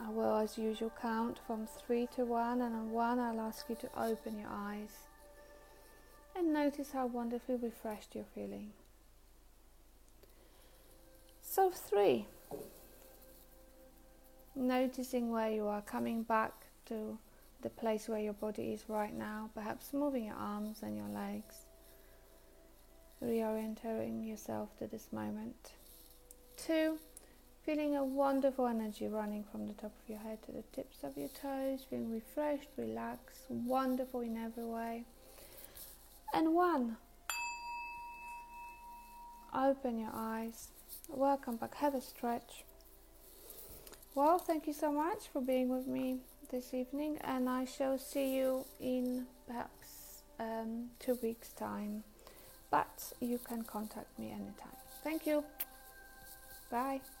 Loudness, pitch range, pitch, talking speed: -39 LUFS, 220-275 Hz, 245 Hz, 125 wpm